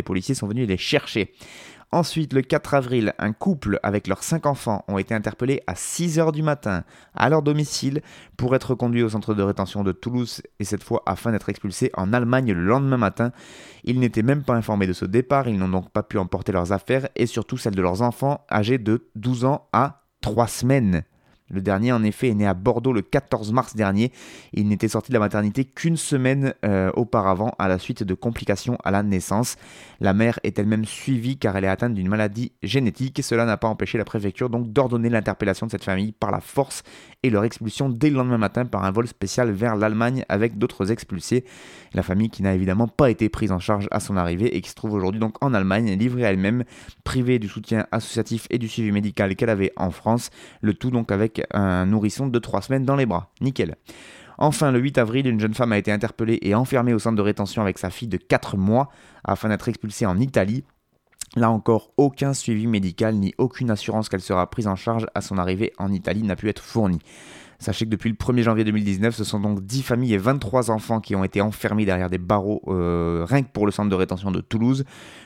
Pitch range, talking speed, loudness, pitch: 100-125 Hz, 220 wpm, -23 LUFS, 110 Hz